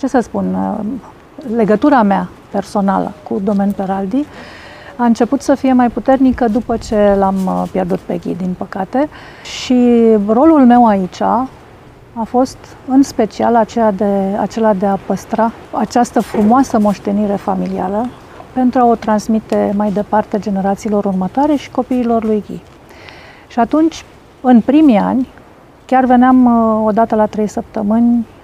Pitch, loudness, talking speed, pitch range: 225 Hz, -14 LUFS, 135 wpm, 205-250 Hz